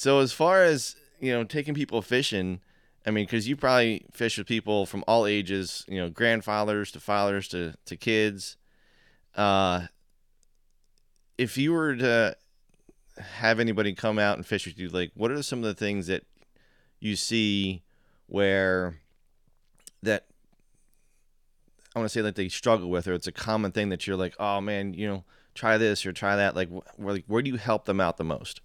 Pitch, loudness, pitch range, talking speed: 105 Hz, -27 LUFS, 95-115 Hz, 185 wpm